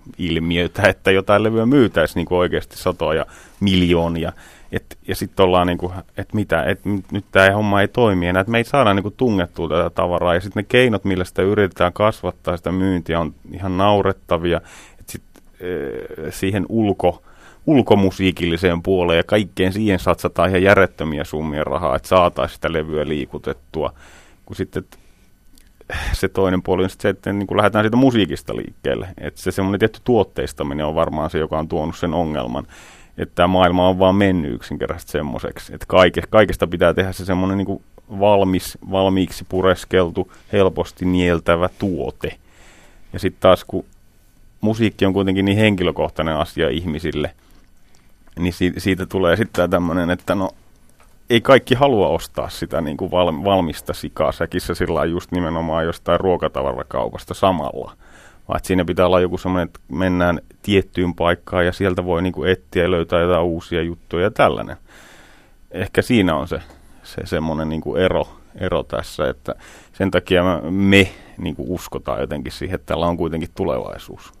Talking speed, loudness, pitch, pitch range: 160 wpm, -19 LUFS, 90 Hz, 85-95 Hz